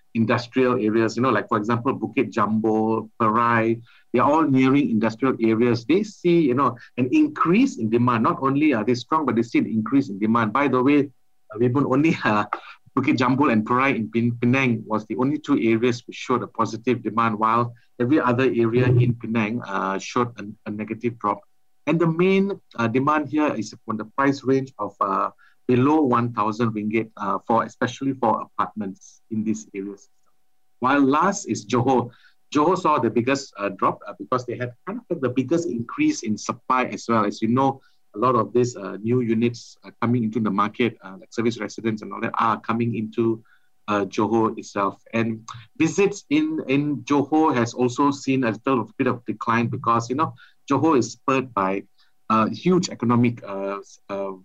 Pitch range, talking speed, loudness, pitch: 110-135 Hz, 190 wpm, -22 LUFS, 120 Hz